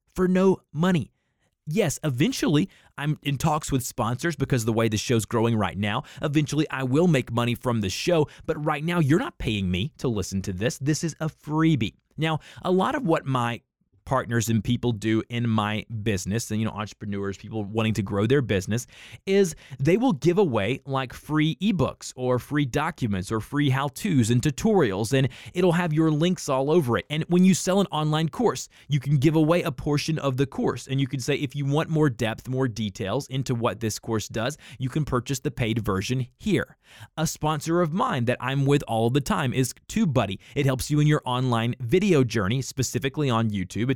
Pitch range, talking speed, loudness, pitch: 115-155 Hz, 210 wpm, -25 LUFS, 135 Hz